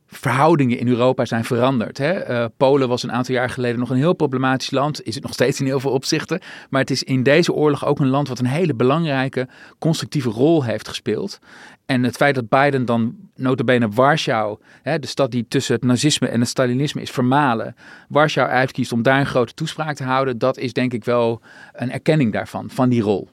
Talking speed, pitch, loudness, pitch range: 215 wpm, 130 Hz, -19 LUFS, 125-145 Hz